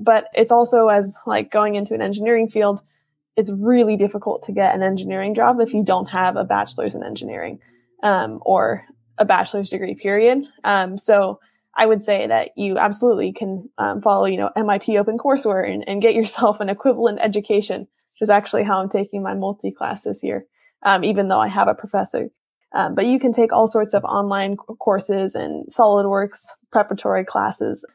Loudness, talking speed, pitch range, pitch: -19 LUFS, 185 wpm, 195-225 Hz, 205 Hz